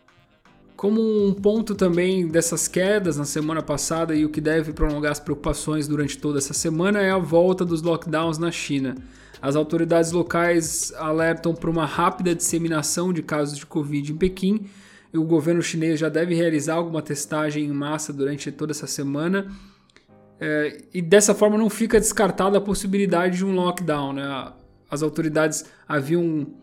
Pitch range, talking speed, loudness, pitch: 150-180 Hz, 160 wpm, -22 LUFS, 165 Hz